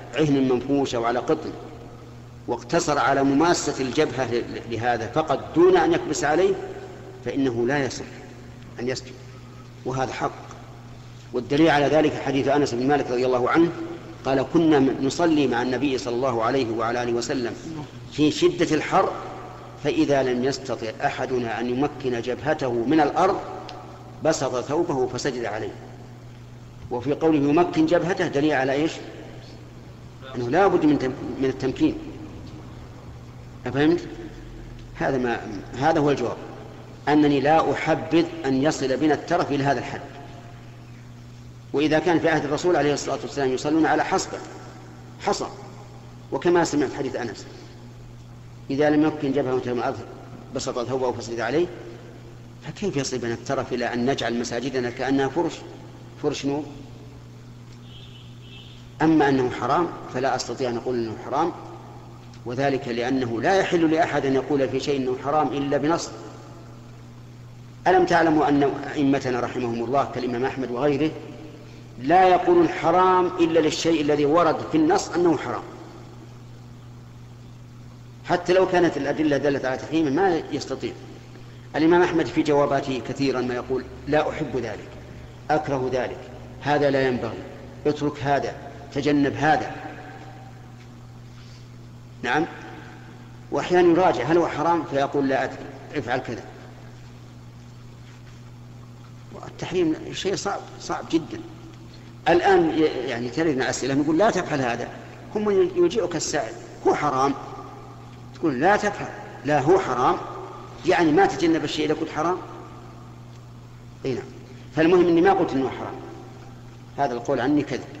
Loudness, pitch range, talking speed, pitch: -23 LUFS, 120-150 Hz, 125 wpm, 130 Hz